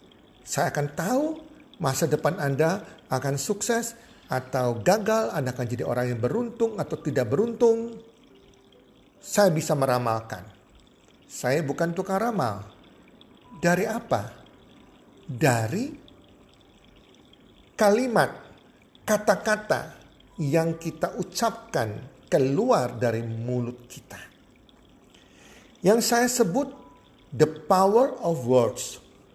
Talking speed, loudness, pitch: 90 wpm, -25 LUFS, 165 Hz